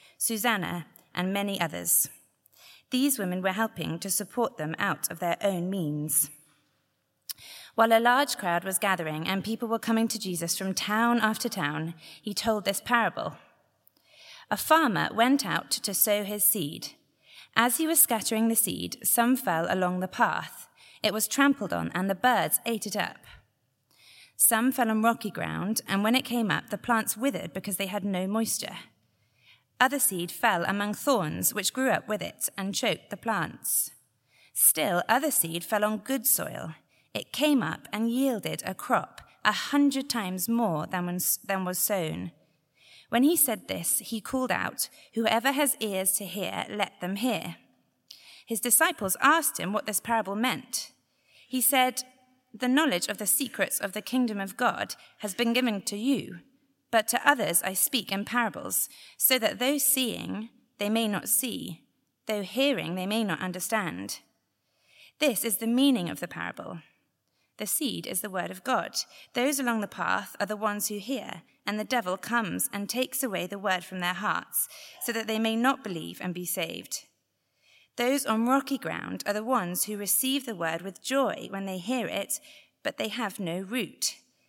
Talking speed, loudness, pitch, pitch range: 175 wpm, -27 LUFS, 220 Hz, 190-250 Hz